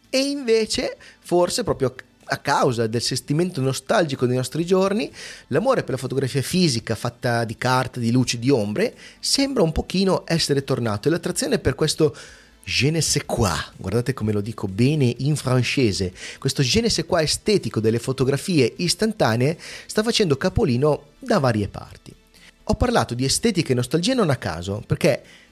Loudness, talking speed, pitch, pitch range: -21 LUFS, 160 wpm, 140 Hz, 125-180 Hz